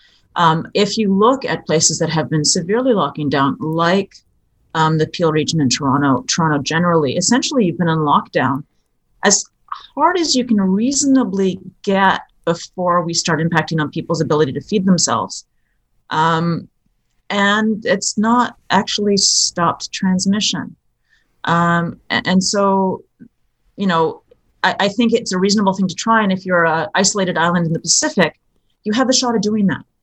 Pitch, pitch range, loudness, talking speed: 185 Hz, 160-210 Hz, -16 LUFS, 160 wpm